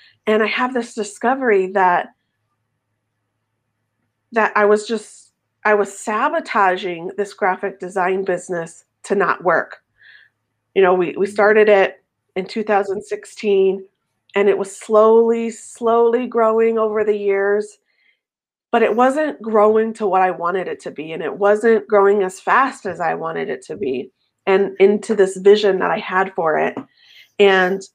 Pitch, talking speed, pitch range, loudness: 200 Hz, 150 wpm, 185-220 Hz, -17 LUFS